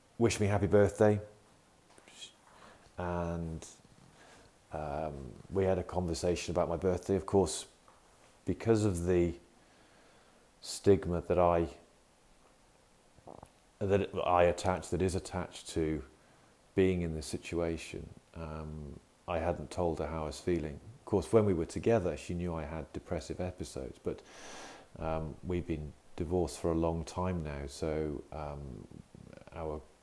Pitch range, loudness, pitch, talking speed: 80-90 Hz, -34 LUFS, 85 Hz, 130 wpm